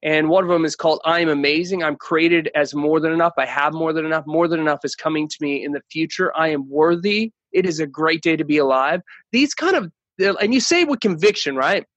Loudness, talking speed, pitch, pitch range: -19 LUFS, 250 wpm, 160 Hz, 150-185 Hz